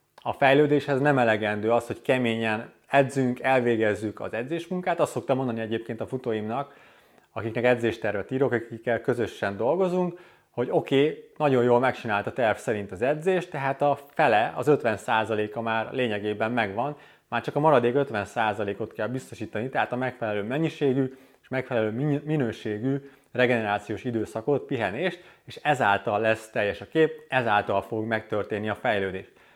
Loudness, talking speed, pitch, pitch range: -26 LUFS, 140 wpm, 120 Hz, 110-140 Hz